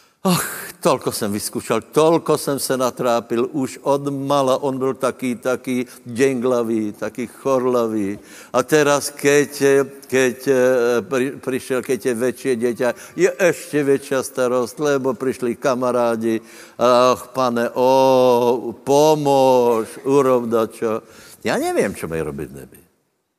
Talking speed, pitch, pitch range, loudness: 120 wpm, 125 Hz, 120-135 Hz, -19 LUFS